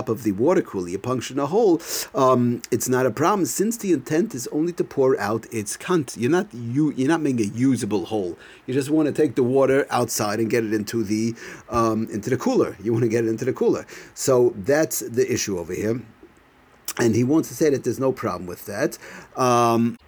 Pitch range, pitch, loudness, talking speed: 115-140 Hz, 125 Hz, -22 LUFS, 225 wpm